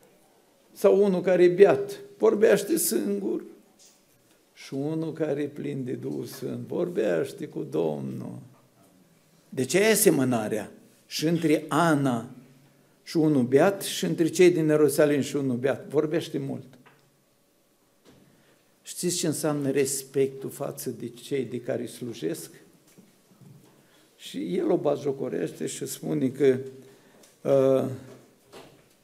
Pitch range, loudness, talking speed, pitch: 135-180 Hz, -25 LUFS, 120 wpm, 150 Hz